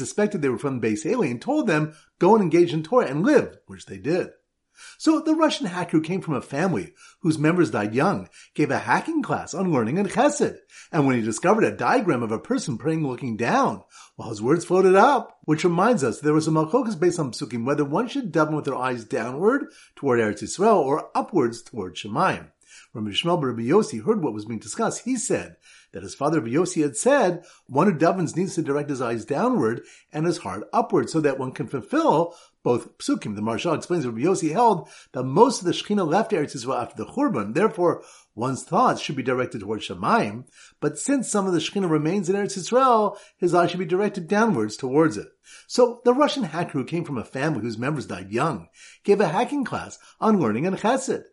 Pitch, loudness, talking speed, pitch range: 170 Hz, -23 LUFS, 215 wpm, 145-210 Hz